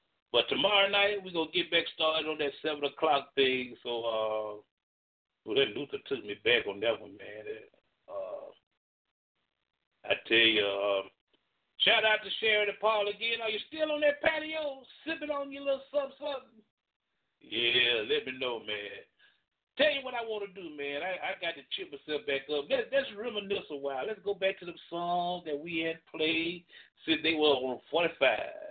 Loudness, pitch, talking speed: -30 LUFS, 200 Hz, 190 wpm